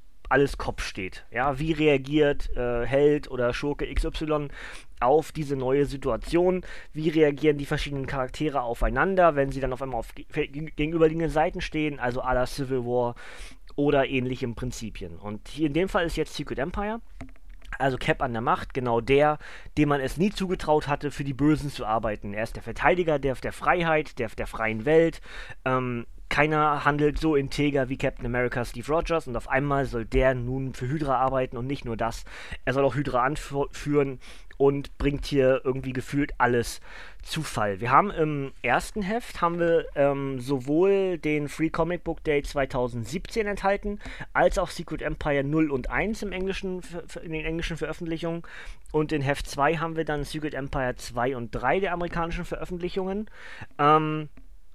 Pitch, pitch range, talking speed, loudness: 145 Hz, 130-160 Hz, 170 wpm, -26 LUFS